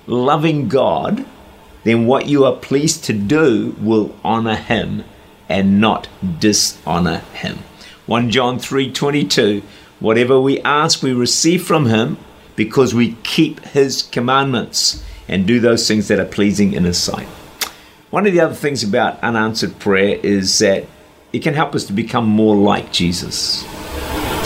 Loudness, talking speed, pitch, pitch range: -16 LUFS, 145 wpm, 115 Hz, 105-135 Hz